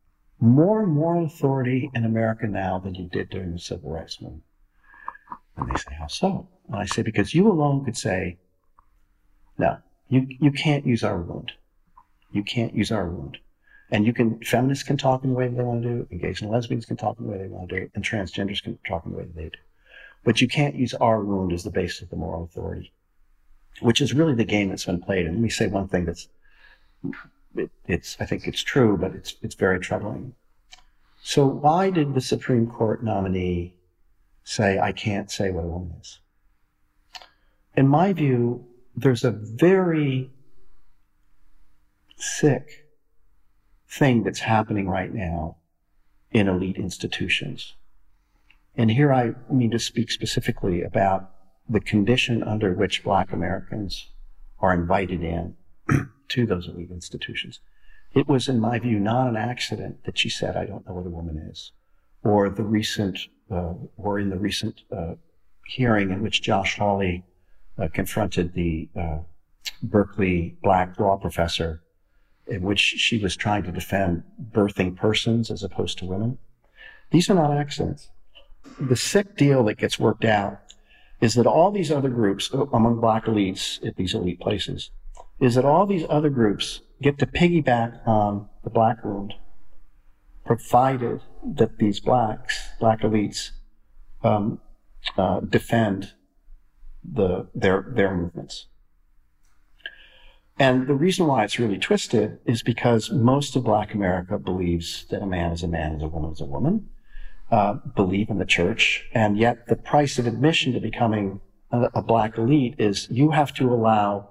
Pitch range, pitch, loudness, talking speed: 95-125 Hz, 105 Hz, -23 LUFS, 165 wpm